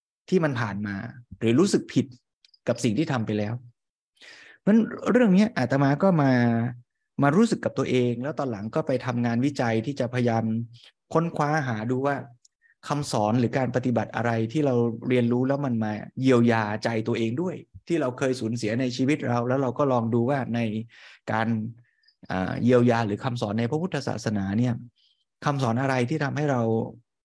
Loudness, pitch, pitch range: -25 LUFS, 120 Hz, 115-140 Hz